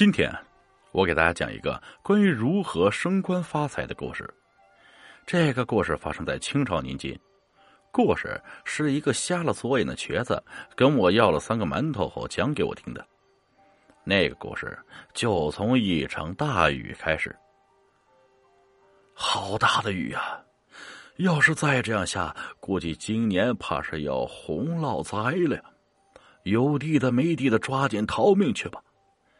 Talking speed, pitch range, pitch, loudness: 210 characters per minute, 110-170 Hz, 135 Hz, -25 LUFS